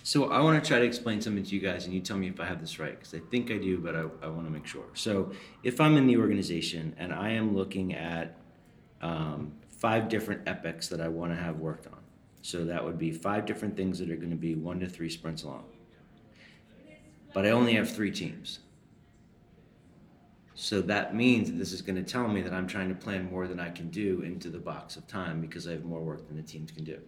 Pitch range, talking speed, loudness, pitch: 80-105 Hz, 250 wpm, -31 LUFS, 90 Hz